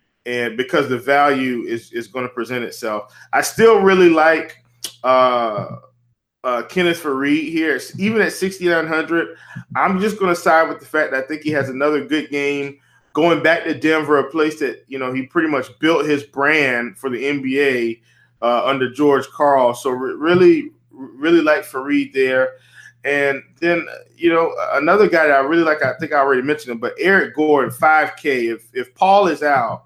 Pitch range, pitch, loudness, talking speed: 130-165 Hz, 145 Hz, -17 LUFS, 185 wpm